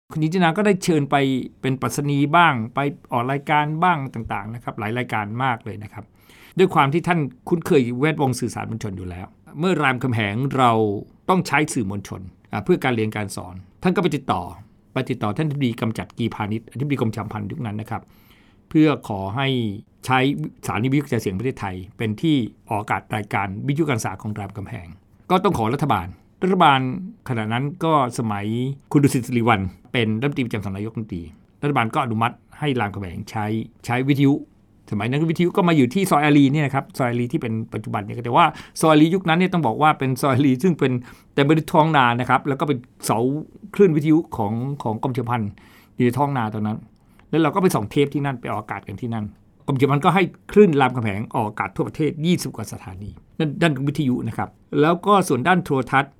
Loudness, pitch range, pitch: -21 LUFS, 110-150 Hz, 125 Hz